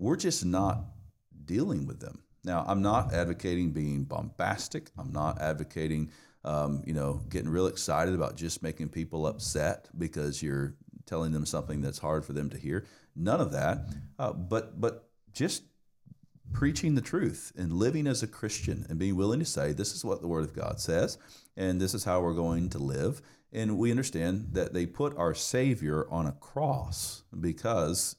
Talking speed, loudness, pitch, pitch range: 180 wpm, -32 LUFS, 90 Hz, 80-110 Hz